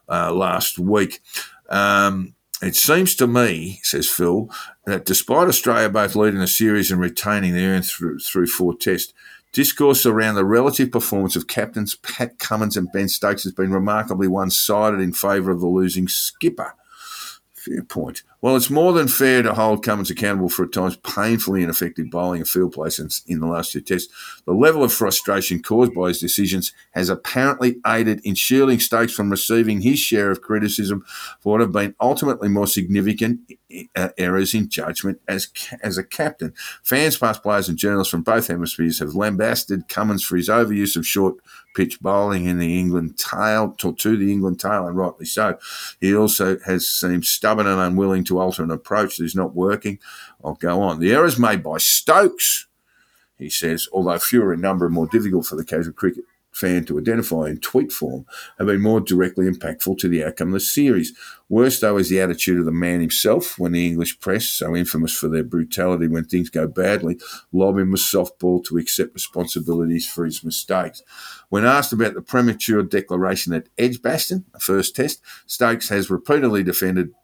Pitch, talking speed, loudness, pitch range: 95 Hz, 185 wpm, -19 LUFS, 90-110 Hz